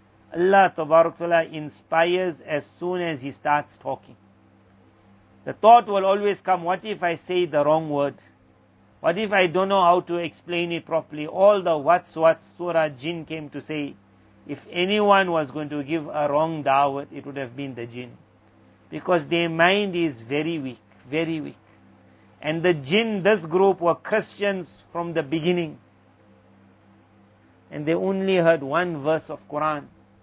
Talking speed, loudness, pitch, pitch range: 160 wpm, -22 LUFS, 160 Hz, 135-175 Hz